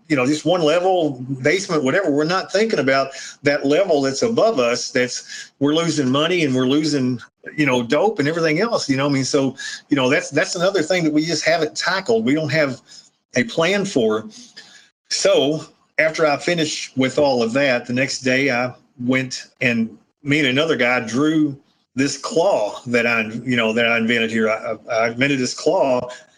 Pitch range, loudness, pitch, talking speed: 125-155 Hz, -19 LUFS, 140 Hz, 200 wpm